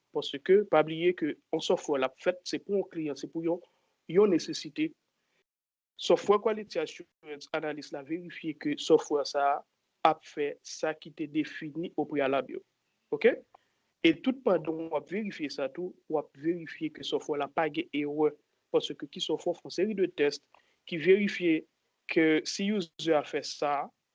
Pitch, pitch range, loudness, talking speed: 165 Hz, 150-205 Hz, -30 LUFS, 165 wpm